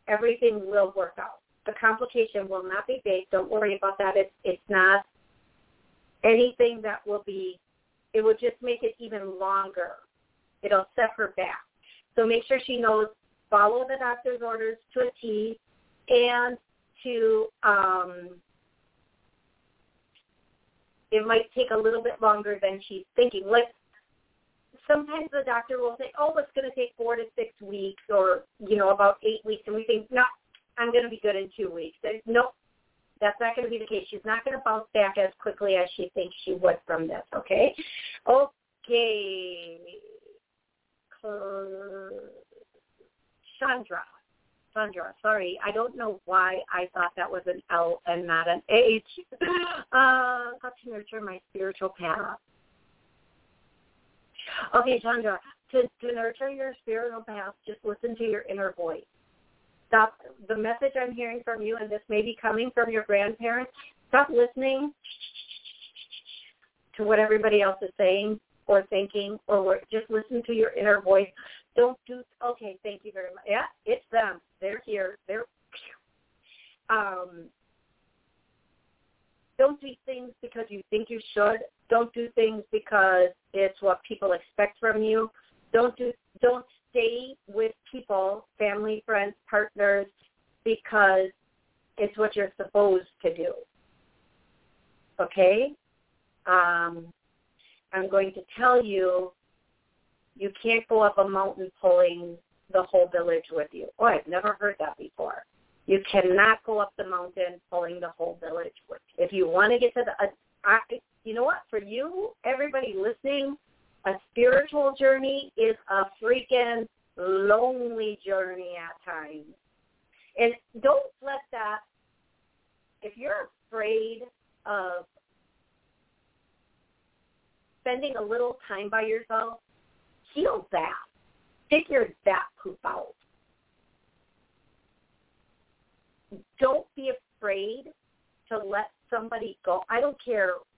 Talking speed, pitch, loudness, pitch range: 140 wpm, 220 Hz, -26 LUFS, 195-245 Hz